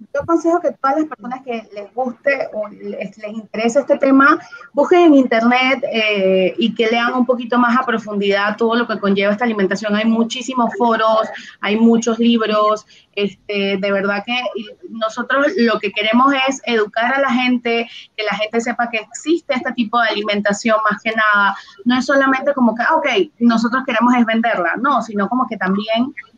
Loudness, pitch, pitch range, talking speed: -16 LUFS, 230 Hz, 210-255 Hz, 185 wpm